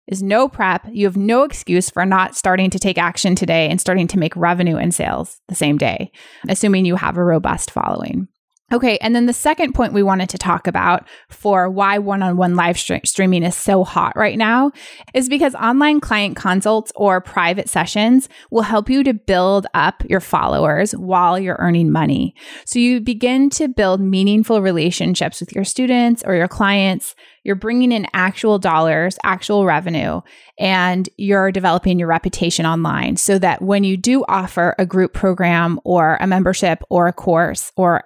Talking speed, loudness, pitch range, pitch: 185 wpm, -16 LUFS, 180-220 Hz, 190 Hz